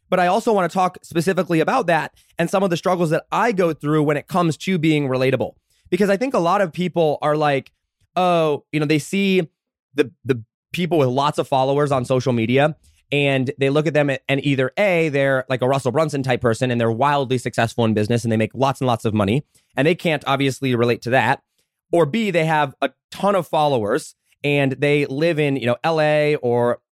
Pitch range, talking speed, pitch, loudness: 130-170 Hz, 225 wpm, 145 Hz, -19 LUFS